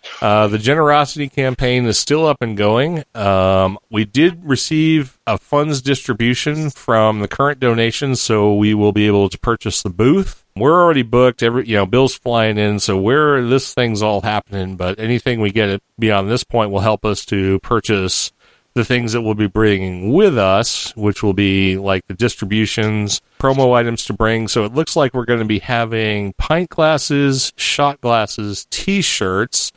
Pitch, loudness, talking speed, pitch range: 115 Hz, -16 LUFS, 175 wpm, 105-130 Hz